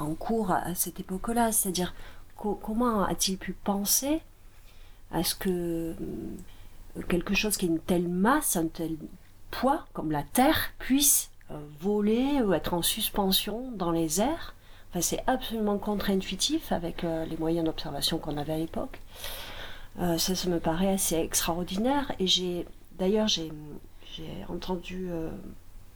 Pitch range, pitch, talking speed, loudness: 165-210 Hz, 180 Hz, 150 wpm, -28 LUFS